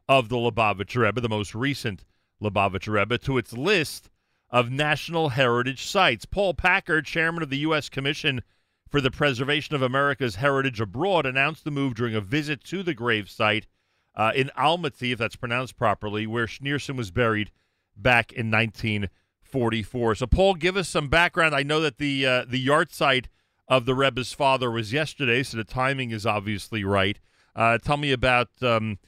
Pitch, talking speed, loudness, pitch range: 125 Hz, 175 wpm, -24 LUFS, 110-145 Hz